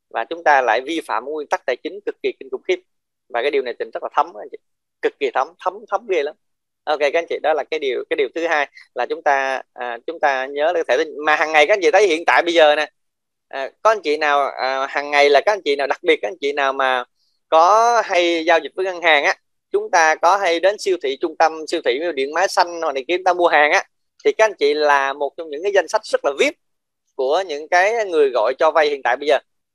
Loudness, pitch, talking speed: -18 LUFS, 175 Hz, 280 wpm